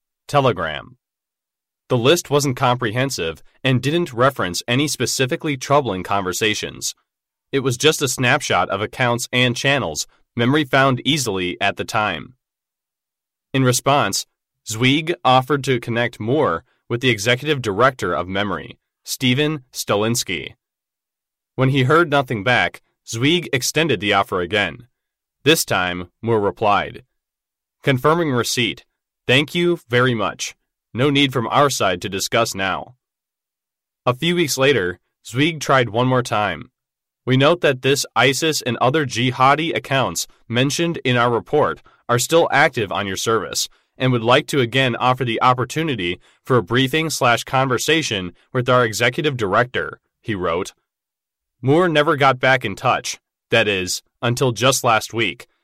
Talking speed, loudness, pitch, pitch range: 135 wpm, -18 LUFS, 130 Hz, 115-140 Hz